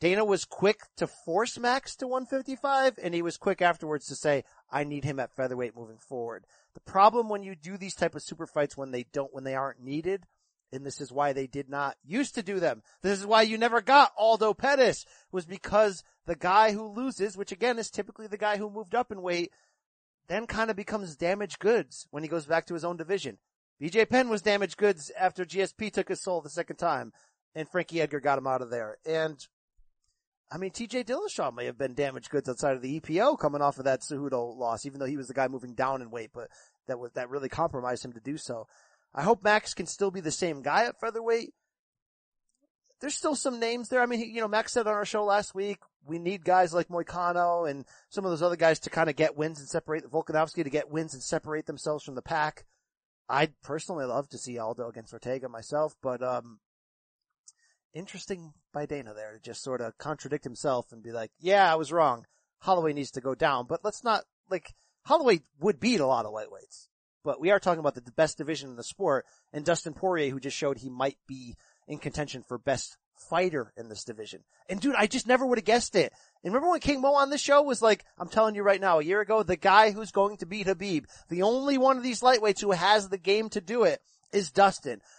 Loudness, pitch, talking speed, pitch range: -28 LUFS, 170 Hz, 230 wpm, 140-210 Hz